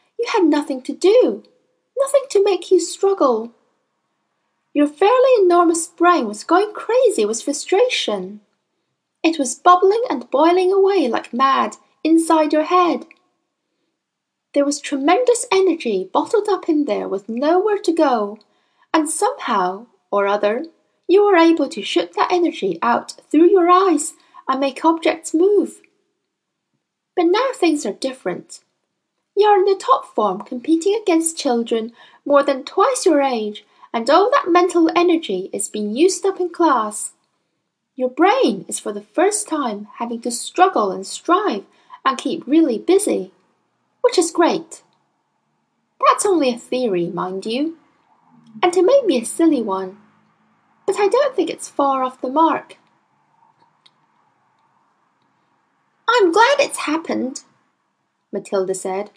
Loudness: -17 LUFS